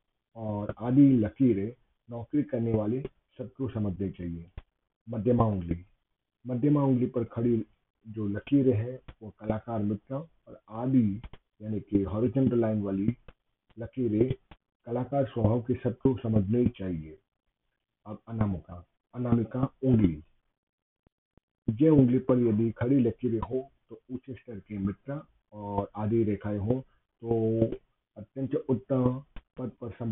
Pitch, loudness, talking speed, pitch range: 115 Hz, -29 LUFS, 120 wpm, 105-125 Hz